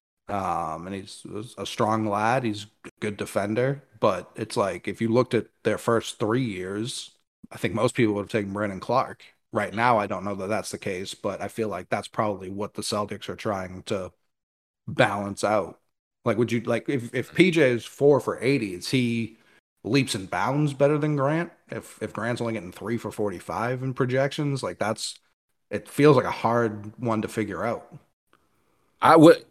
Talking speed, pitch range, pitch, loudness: 195 wpm, 105-130 Hz, 115 Hz, -25 LUFS